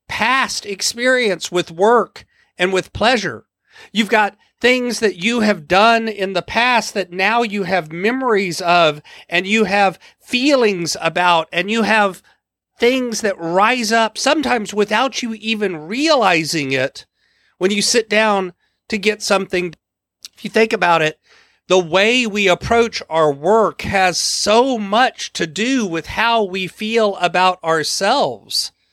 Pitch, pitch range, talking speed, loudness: 205 Hz, 180-230 Hz, 145 wpm, -16 LUFS